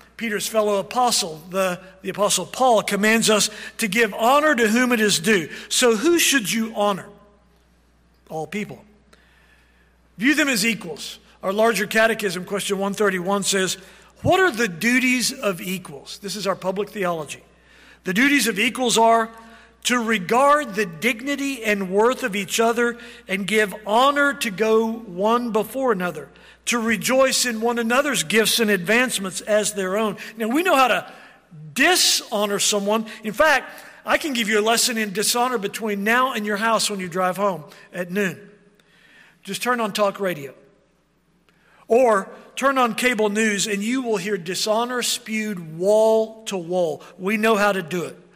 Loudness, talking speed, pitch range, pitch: -20 LUFS, 165 wpm, 200-235 Hz, 215 Hz